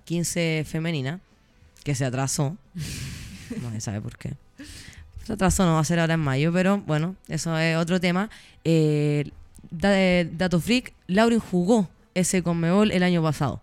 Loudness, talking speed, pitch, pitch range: -24 LUFS, 155 wpm, 165 Hz, 140-185 Hz